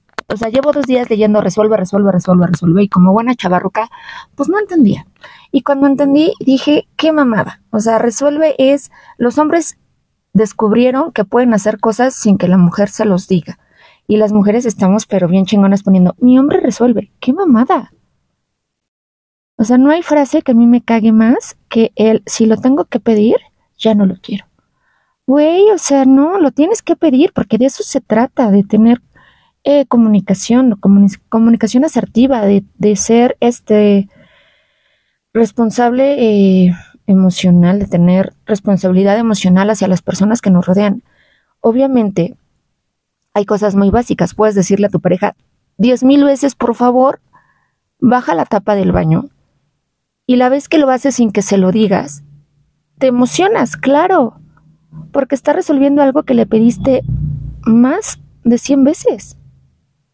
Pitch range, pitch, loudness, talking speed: 200-270 Hz, 225 Hz, -12 LUFS, 160 wpm